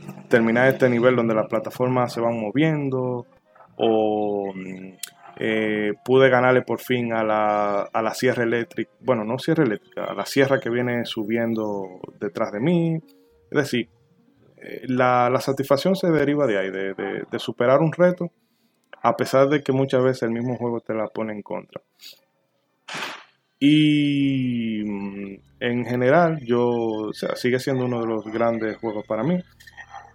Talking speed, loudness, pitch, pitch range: 155 wpm, -22 LUFS, 120 Hz, 110-135 Hz